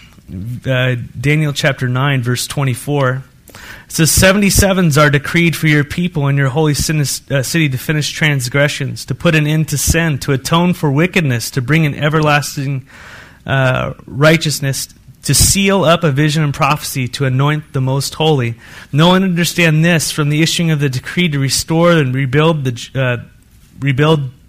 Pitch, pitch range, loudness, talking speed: 145 Hz, 130-160 Hz, -14 LUFS, 160 wpm